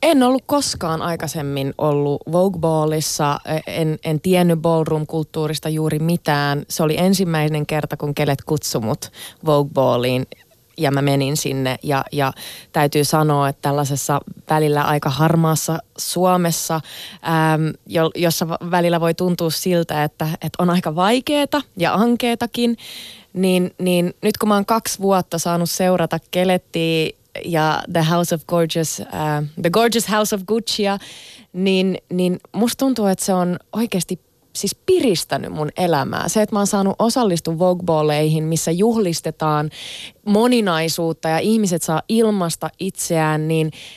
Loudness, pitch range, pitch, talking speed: -19 LUFS, 155-190 Hz, 165 Hz, 135 wpm